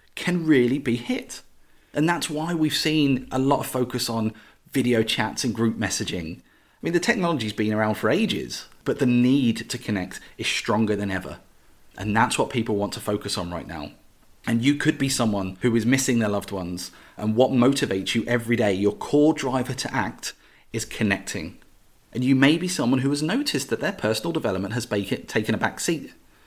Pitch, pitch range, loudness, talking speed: 120 Hz, 105-140 Hz, -24 LUFS, 195 wpm